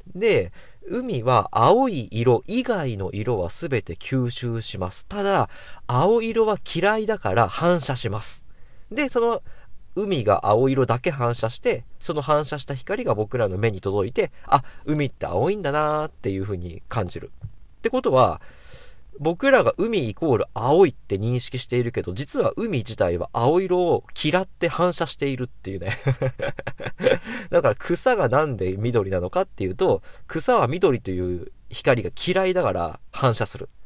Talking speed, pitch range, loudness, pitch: 290 characters per minute, 110-180 Hz, -23 LUFS, 135 Hz